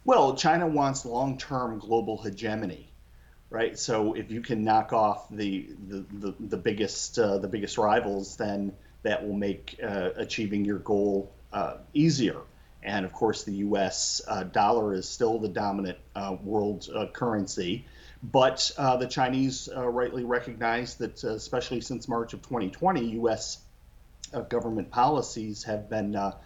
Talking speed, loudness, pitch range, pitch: 155 wpm, -29 LUFS, 100-125 Hz, 110 Hz